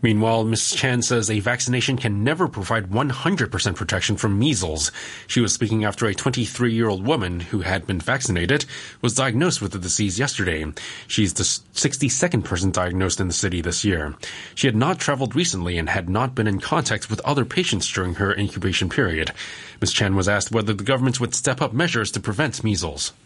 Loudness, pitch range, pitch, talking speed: -22 LUFS, 95-130 Hz, 110 Hz, 185 wpm